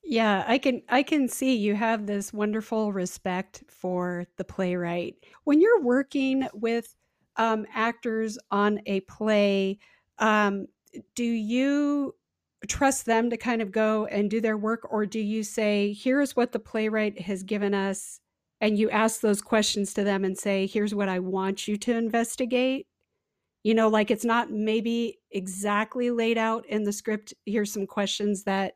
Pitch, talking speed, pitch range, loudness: 215 Hz, 165 wpm, 205-235 Hz, -26 LUFS